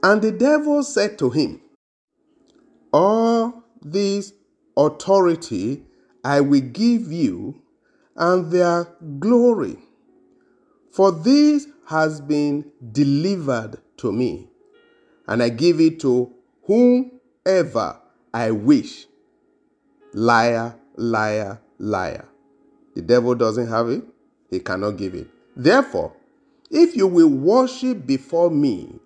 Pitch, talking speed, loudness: 180 Hz, 105 wpm, -19 LUFS